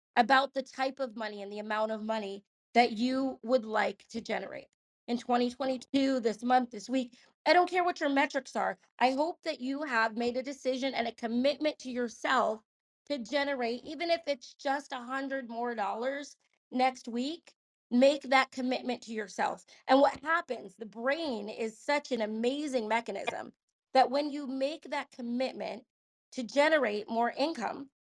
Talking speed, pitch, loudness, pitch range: 170 wpm, 255 Hz, -31 LUFS, 230-280 Hz